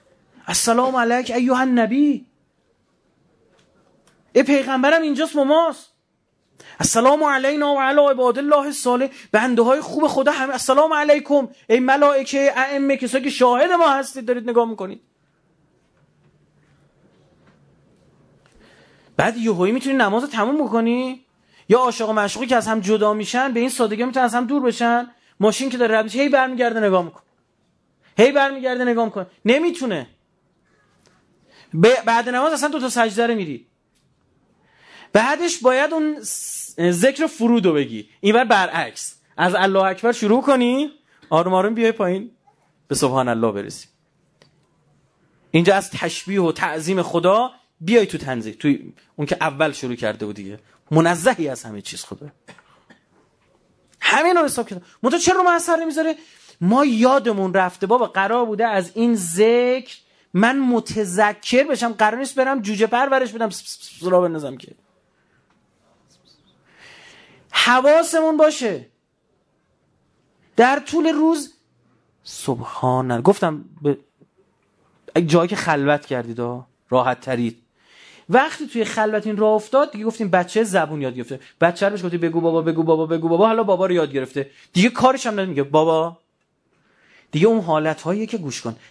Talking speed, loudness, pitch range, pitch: 140 wpm, -19 LUFS, 170-265 Hz, 225 Hz